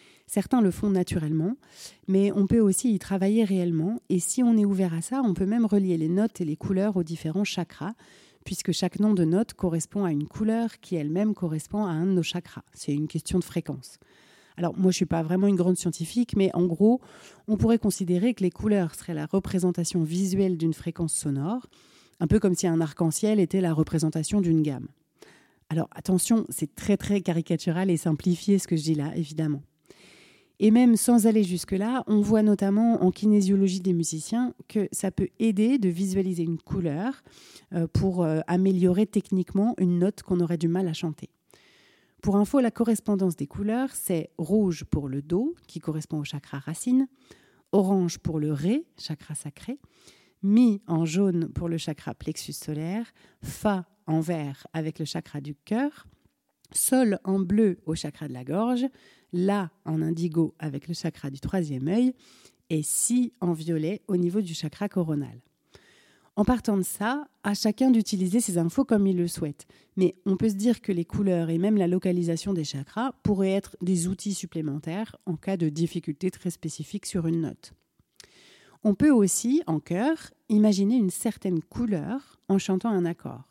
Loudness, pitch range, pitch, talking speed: -26 LUFS, 165-210 Hz, 185 Hz, 180 wpm